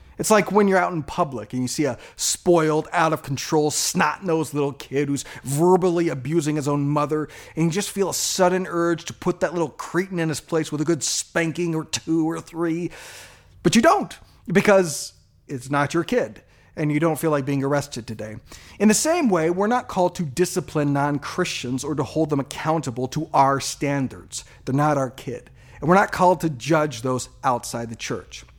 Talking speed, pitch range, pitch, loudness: 205 wpm, 135-170 Hz, 155 Hz, -22 LUFS